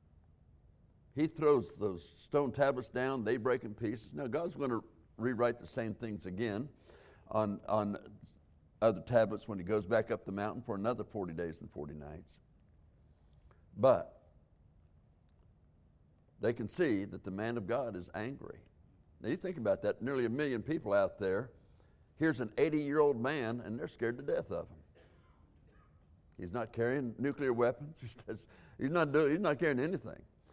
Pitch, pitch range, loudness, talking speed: 105 Hz, 80-120 Hz, -35 LUFS, 165 wpm